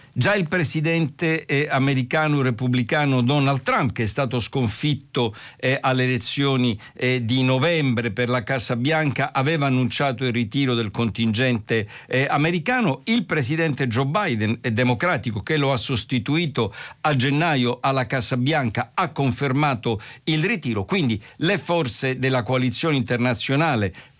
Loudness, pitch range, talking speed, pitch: -22 LUFS, 125-150 Hz, 120 wpm, 130 Hz